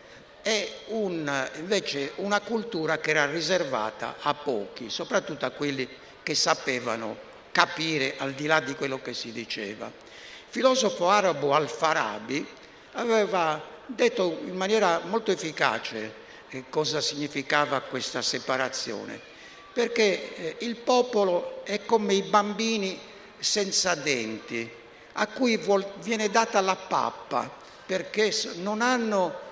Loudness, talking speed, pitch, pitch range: -27 LUFS, 115 wpm, 185 Hz, 145-215 Hz